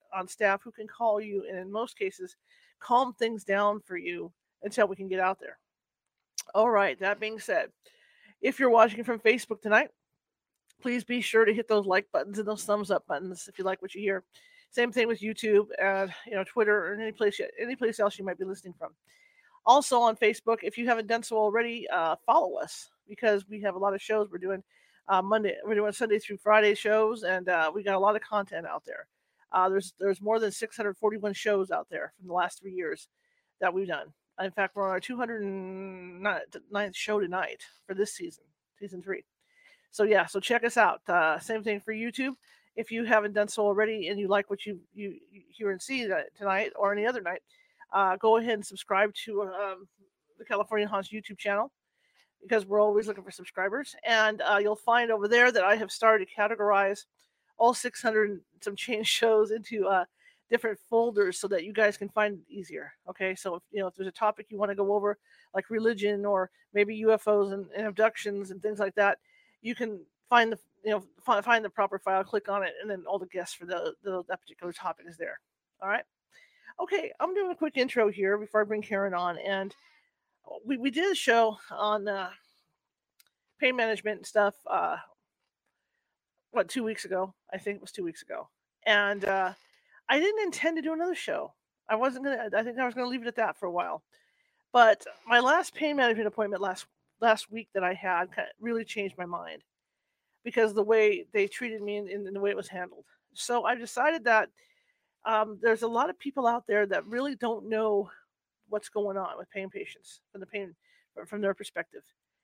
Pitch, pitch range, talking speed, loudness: 210 Hz, 195-235 Hz, 210 wpm, -28 LUFS